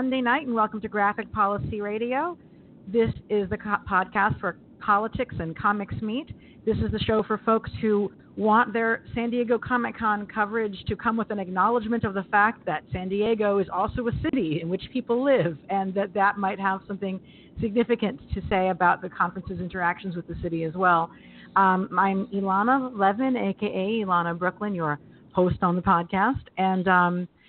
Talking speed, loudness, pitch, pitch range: 175 wpm, -25 LUFS, 200 Hz, 185-225 Hz